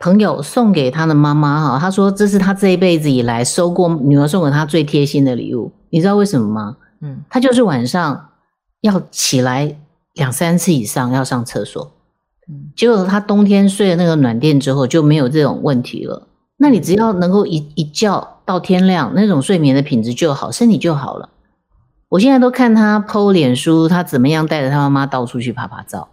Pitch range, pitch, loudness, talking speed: 140-195 Hz, 160 Hz, -14 LUFS, 295 characters per minute